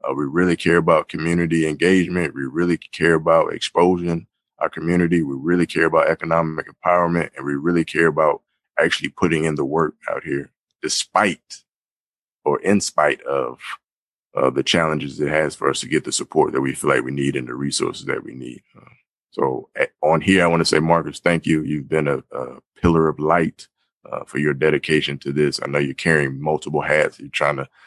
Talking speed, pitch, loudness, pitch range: 200 wpm, 80 Hz, -20 LUFS, 75-85 Hz